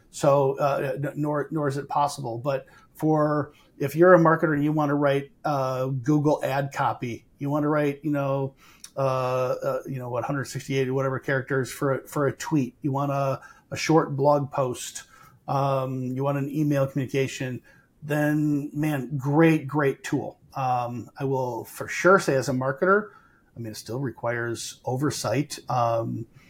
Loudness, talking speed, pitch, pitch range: -25 LUFS, 170 wpm, 140 Hz, 130-150 Hz